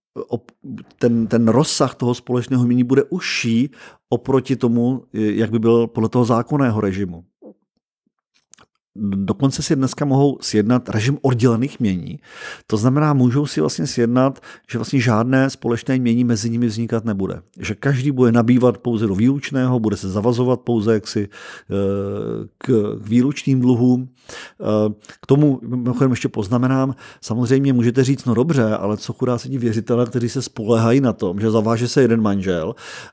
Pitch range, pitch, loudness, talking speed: 115-130 Hz, 120 Hz, -18 LUFS, 145 wpm